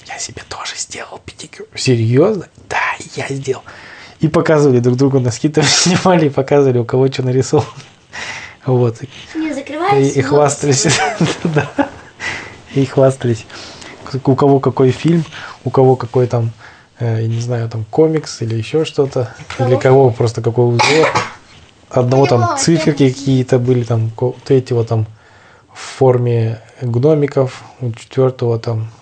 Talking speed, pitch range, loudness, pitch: 125 wpm, 120-140 Hz, -14 LUFS, 130 Hz